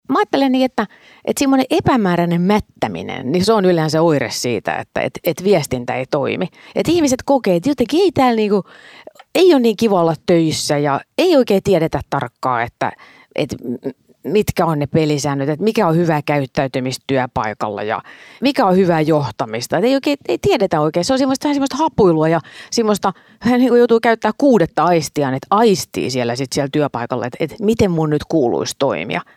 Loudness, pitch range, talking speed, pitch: -16 LUFS, 145-235 Hz, 180 wpm, 180 Hz